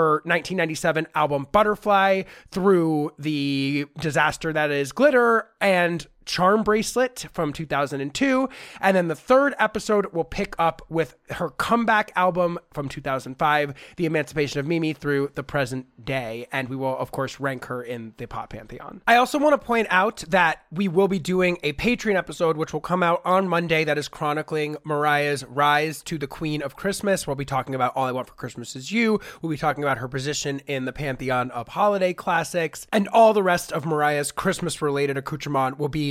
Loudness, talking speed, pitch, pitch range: -23 LUFS, 185 wpm, 155 Hz, 145-190 Hz